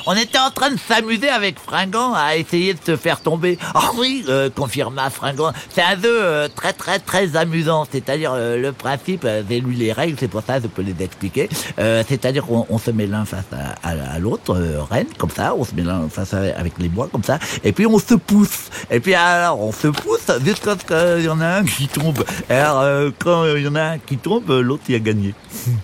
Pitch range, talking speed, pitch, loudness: 115-175 Hz, 245 wpm, 145 Hz, -18 LUFS